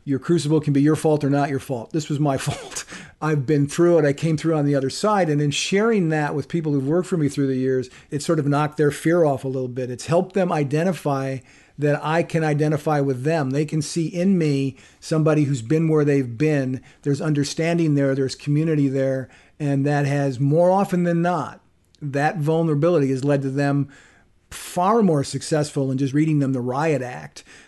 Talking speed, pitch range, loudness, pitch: 210 wpm, 140-160 Hz, -21 LUFS, 145 Hz